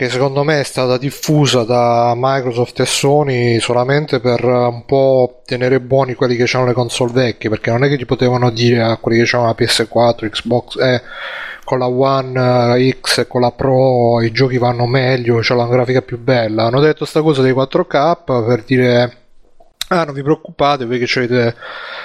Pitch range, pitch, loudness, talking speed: 120-135 Hz, 125 Hz, -14 LUFS, 190 wpm